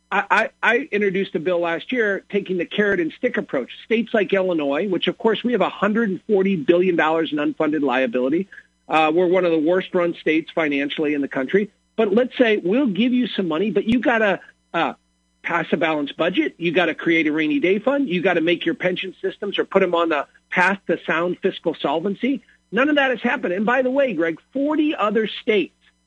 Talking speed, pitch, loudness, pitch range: 215 wpm, 185 Hz, -20 LUFS, 165-220 Hz